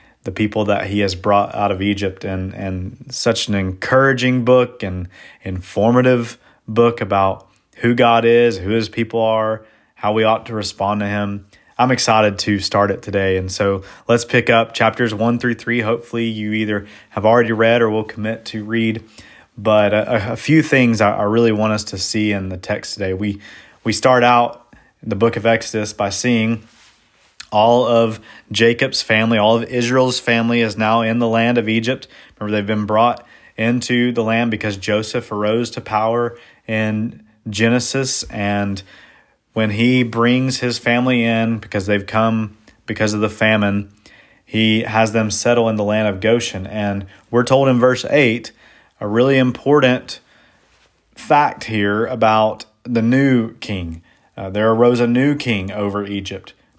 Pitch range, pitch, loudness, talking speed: 105-120 Hz, 110 Hz, -17 LUFS, 170 wpm